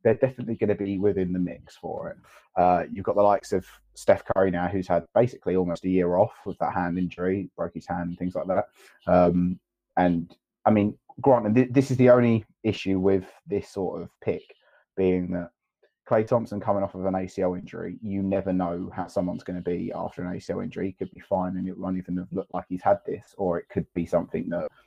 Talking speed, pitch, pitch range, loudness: 230 wpm, 95 Hz, 90-100 Hz, -26 LUFS